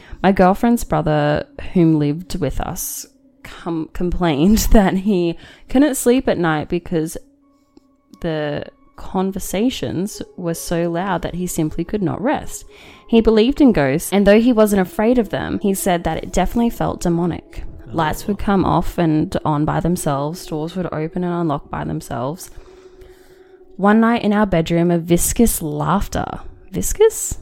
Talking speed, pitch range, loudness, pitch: 150 wpm, 165-235 Hz, -18 LUFS, 185 Hz